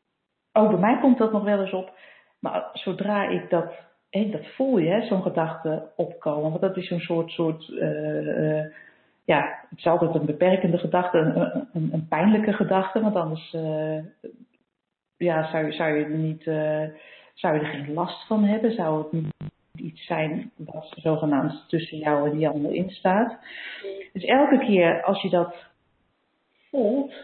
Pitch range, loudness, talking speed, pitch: 155-195 Hz, -24 LUFS, 170 wpm, 170 Hz